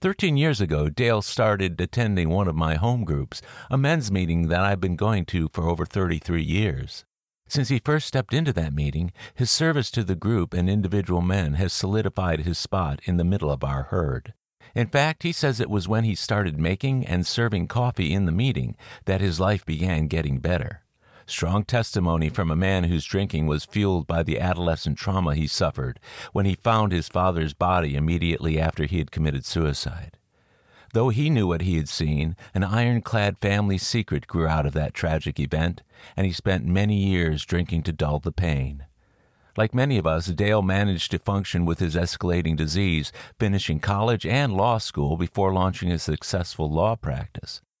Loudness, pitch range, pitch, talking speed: -24 LUFS, 80-105 Hz, 90 Hz, 185 wpm